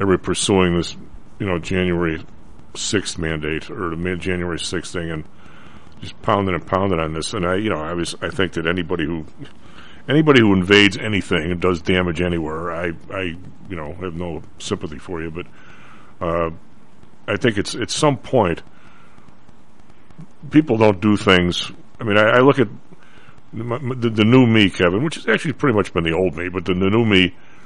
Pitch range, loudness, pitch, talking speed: 85-105 Hz, -19 LUFS, 90 Hz, 190 wpm